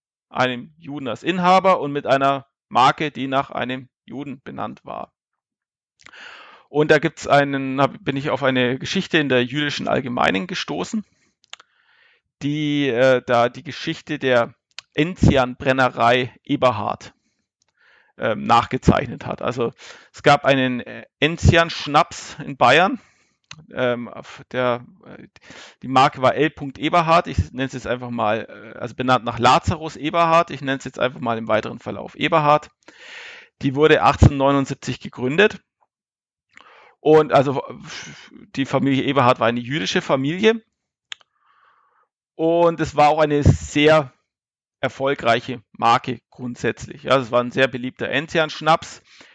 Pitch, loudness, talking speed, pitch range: 135 Hz, -19 LUFS, 125 wpm, 125-155 Hz